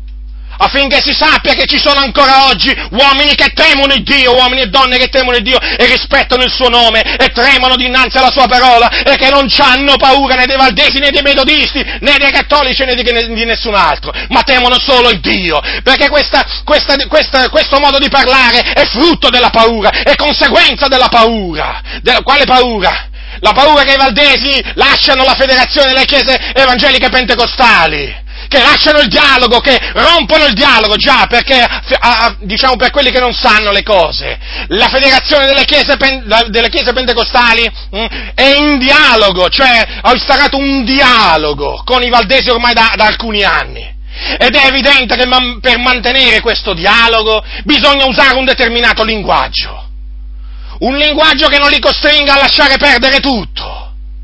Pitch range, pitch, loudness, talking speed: 235-280 Hz, 260 Hz, -7 LUFS, 175 wpm